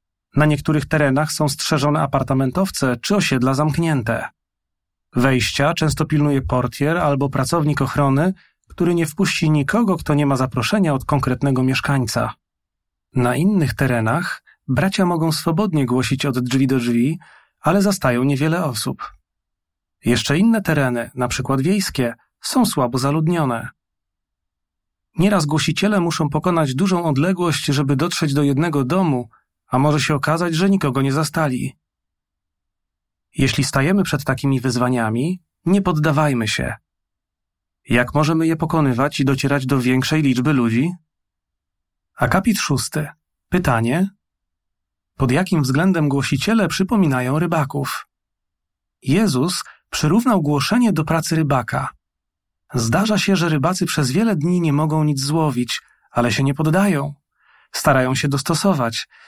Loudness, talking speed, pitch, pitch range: -19 LUFS, 125 wpm, 140 Hz, 125-165 Hz